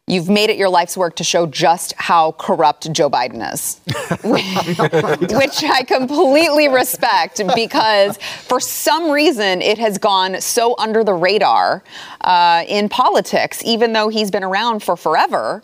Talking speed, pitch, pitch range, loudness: 150 wpm, 210 Hz, 180-240 Hz, -15 LUFS